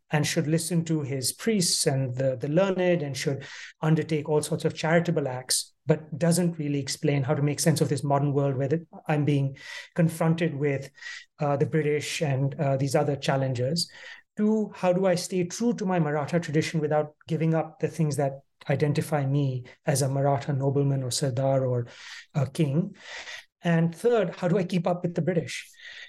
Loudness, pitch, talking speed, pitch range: -26 LUFS, 155 Hz, 185 wpm, 140-170 Hz